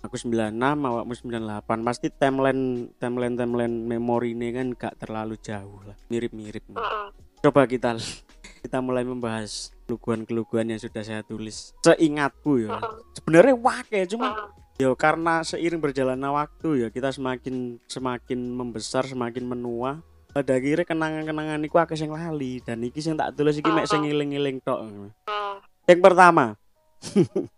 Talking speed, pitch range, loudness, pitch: 135 wpm, 115-150 Hz, -24 LUFS, 125 Hz